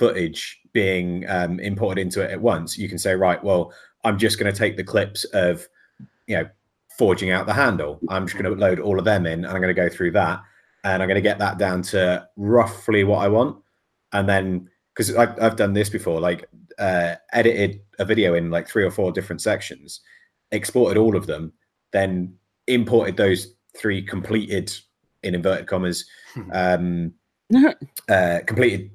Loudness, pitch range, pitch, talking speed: -21 LUFS, 90-105 Hz, 95 Hz, 185 wpm